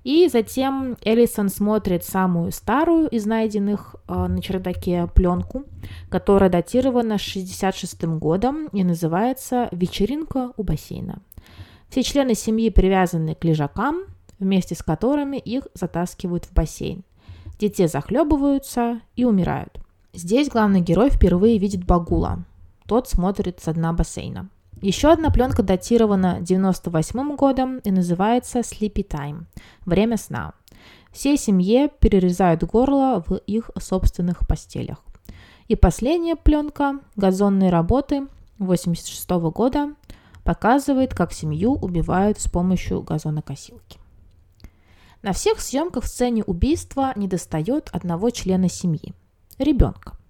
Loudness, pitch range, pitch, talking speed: -21 LUFS, 170-245 Hz, 195 Hz, 110 wpm